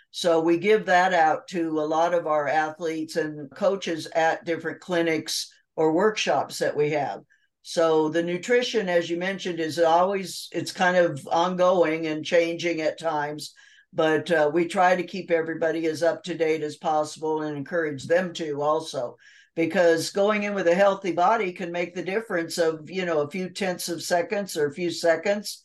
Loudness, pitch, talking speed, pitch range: -24 LUFS, 170 Hz, 180 wpm, 160-180 Hz